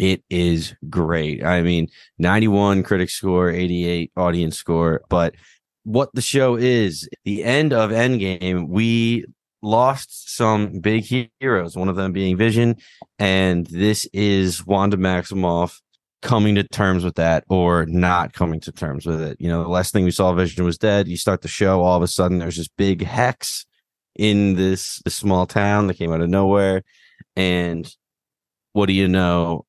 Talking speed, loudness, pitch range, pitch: 170 wpm, -19 LUFS, 85-100 Hz, 95 Hz